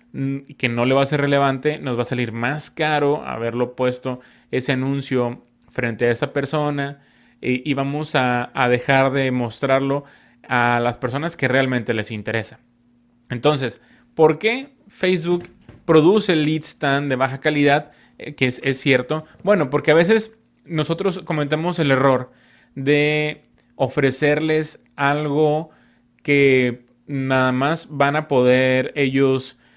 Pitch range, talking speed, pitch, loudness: 125-150 Hz, 135 wpm, 135 Hz, -20 LUFS